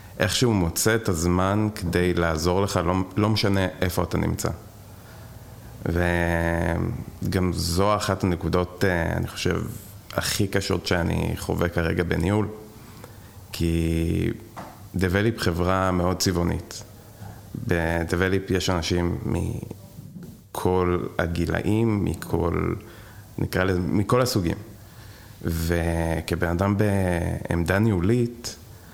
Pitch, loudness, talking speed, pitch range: 95 Hz, -24 LUFS, 95 wpm, 85-105 Hz